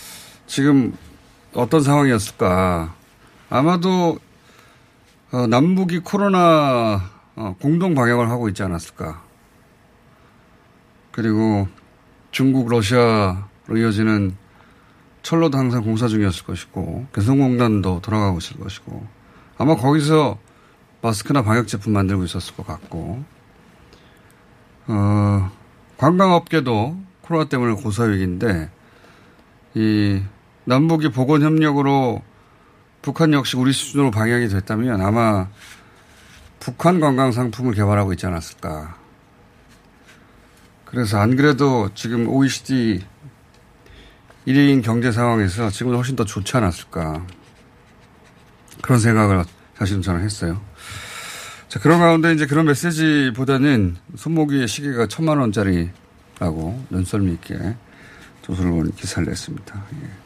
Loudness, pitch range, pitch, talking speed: -19 LUFS, 100-140 Hz, 120 Hz, 250 characters per minute